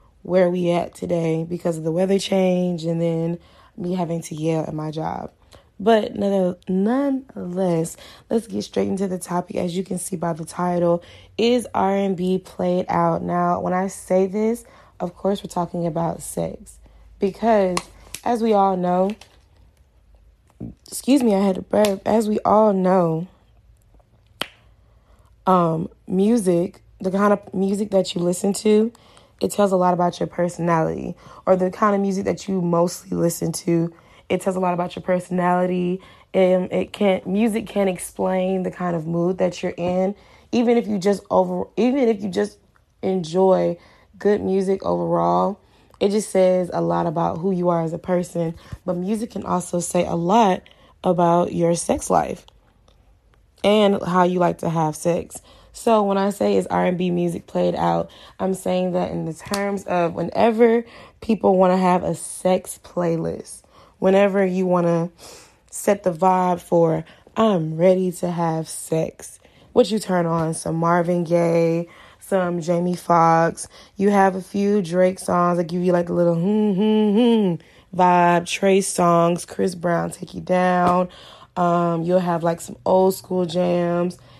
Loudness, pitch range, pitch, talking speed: -21 LUFS, 170-195 Hz, 180 Hz, 165 wpm